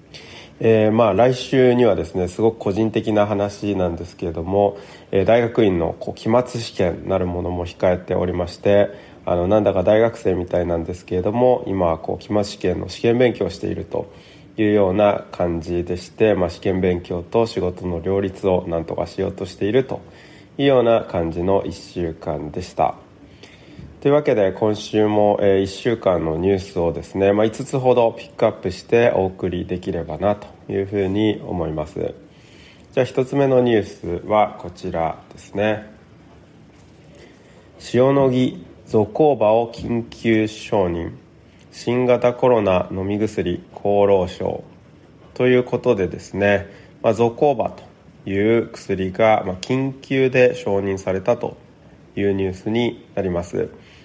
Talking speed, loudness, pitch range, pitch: 300 characters per minute, -20 LUFS, 90-115 Hz, 100 Hz